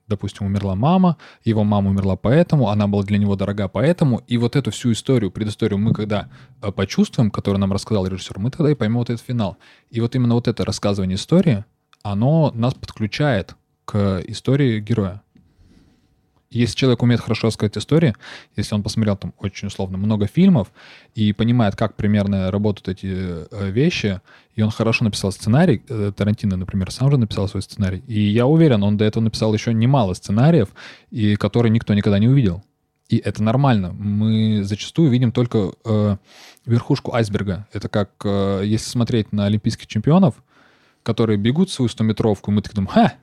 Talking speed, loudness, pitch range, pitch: 170 wpm, -19 LUFS, 100-120 Hz, 110 Hz